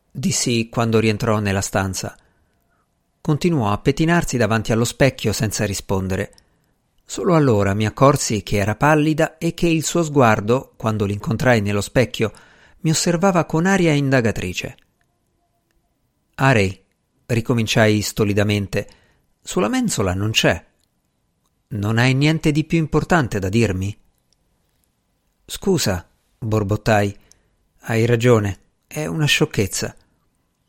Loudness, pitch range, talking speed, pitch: -19 LUFS, 100-150 Hz, 110 wpm, 115 Hz